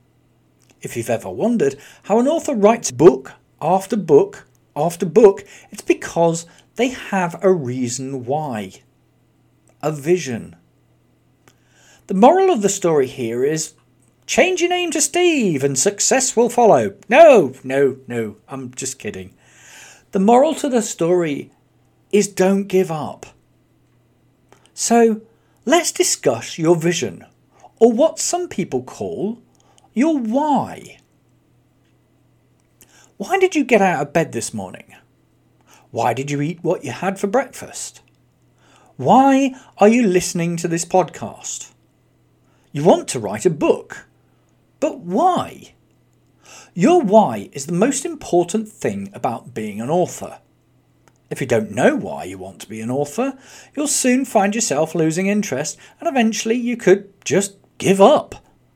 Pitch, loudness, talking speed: 195 Hz, -18 LUFS, 135 wpm